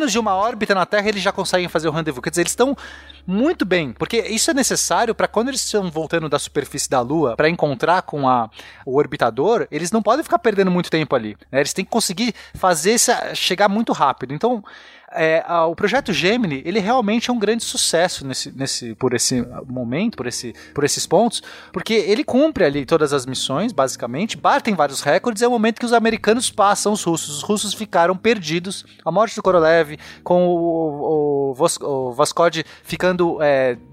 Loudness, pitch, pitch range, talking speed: -19 LUFS, 180 Hz, 150-220 Hz, 195 wpm